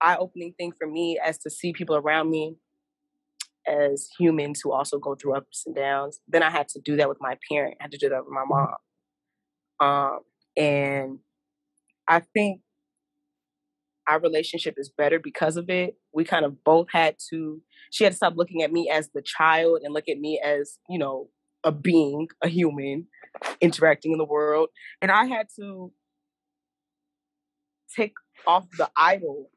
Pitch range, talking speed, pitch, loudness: 150-195 Hz, 175 wpm, 160 Hz, -24 LUFS